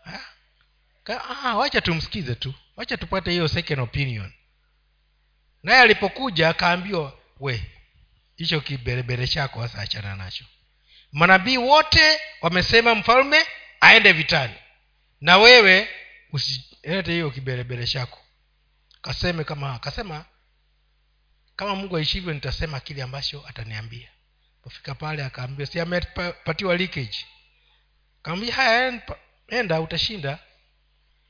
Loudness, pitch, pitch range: -19 LUFS, 145 Hz, 120-180 Hz